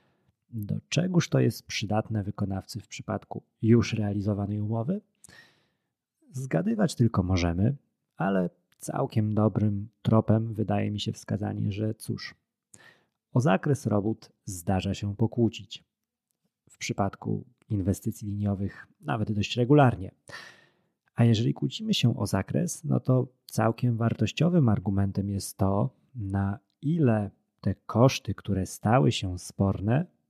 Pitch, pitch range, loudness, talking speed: 110 Hz, 100-125 Hz, -28 LUFS, 115 wpm